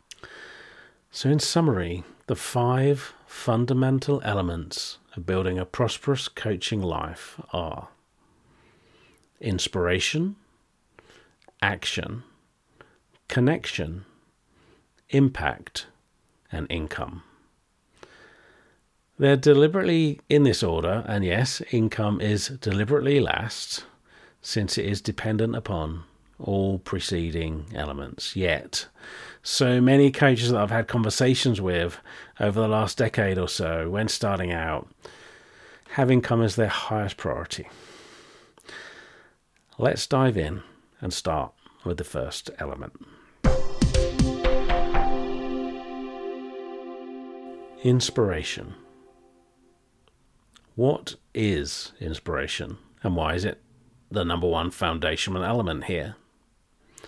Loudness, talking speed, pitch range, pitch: -25 LUFS, 90 wpm, 85-130 Hz, 105 Hz